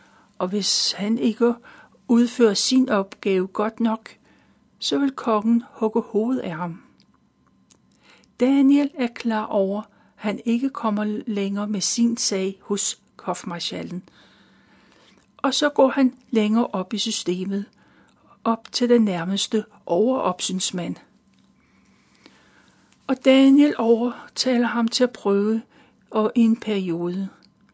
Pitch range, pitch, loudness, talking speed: 200-245 Hz, 220 Hz, -22 LUFS, 115 wpm